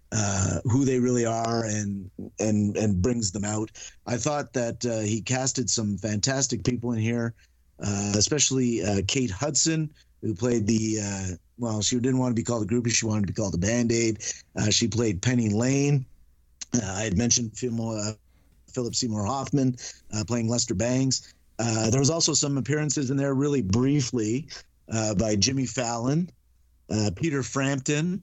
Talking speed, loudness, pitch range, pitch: 180 wpm, -26 LUFS, 105-130 Hz, 115 Hz